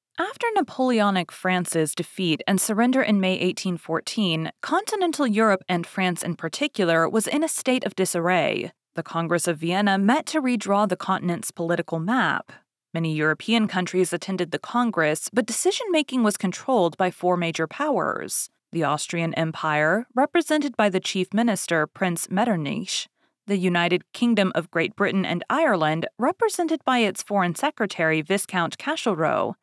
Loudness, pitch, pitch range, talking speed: -23 LUFS, 190 Hz, 170-245 Hz, 145 wpm